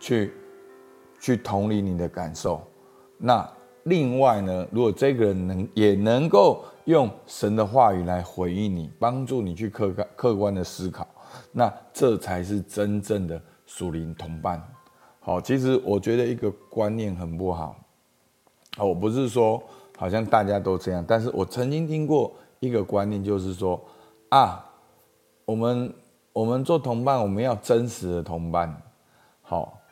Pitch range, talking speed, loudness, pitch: 90-120 Hz, 215 characters per minute, -25 LUFS, 105 Hz